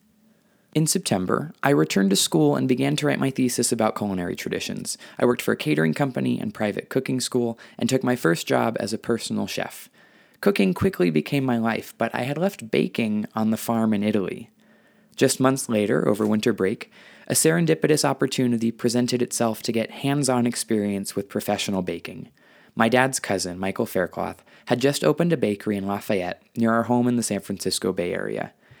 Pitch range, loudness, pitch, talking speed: 100-130 Hz, -23 LUFS, 115 Hz, 185 wpm